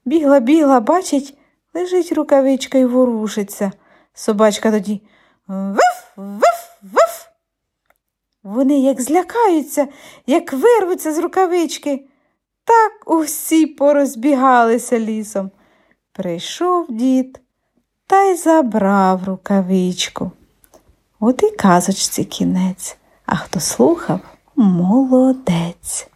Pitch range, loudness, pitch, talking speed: 215-320 Hz, -16 LUFS, 270 Hz, 80 wpm